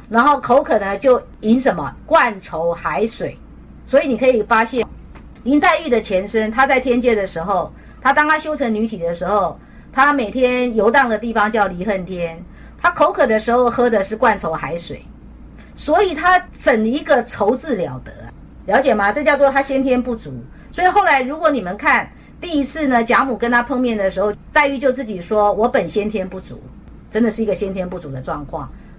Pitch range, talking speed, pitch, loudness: 205-275 Hz, 280 characters per minute, 235 Hz, -17 LUFS